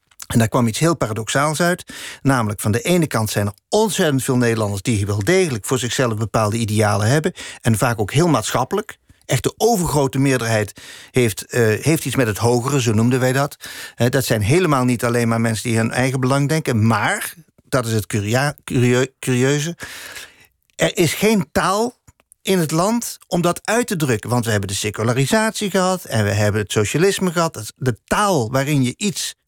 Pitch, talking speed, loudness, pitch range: 130 Hz, 190 wpm, -18 LUFS, 115-160 Hz